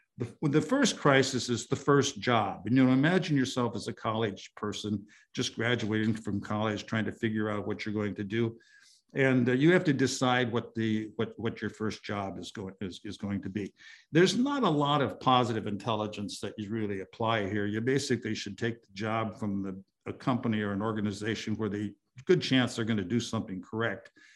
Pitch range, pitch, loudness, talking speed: 105-125 Hz, 110 Hz, -30 LUFS, 205 wpm